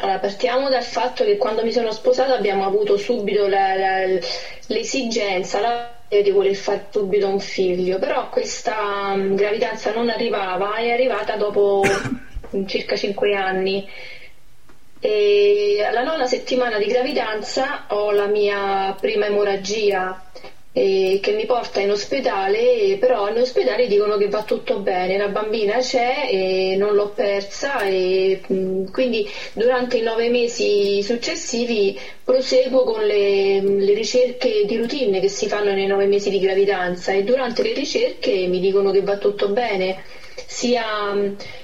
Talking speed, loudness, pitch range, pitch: 140 wpm, -20 LUFS, 195-260 Hz, 210 Hz